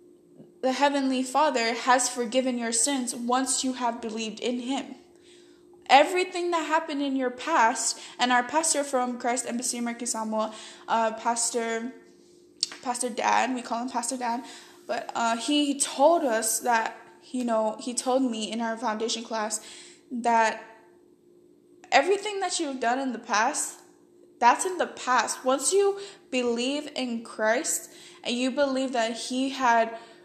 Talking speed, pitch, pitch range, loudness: 145 wpm, 255 Hz, 235-320 Hz, -26 LUFS